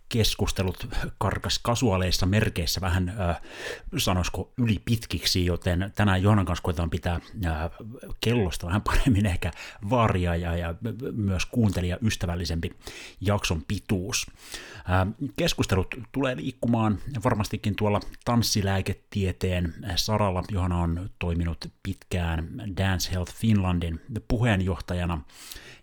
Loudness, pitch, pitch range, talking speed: -27 LUFS, 95 Hz, 90-110 Hz, 95 wpm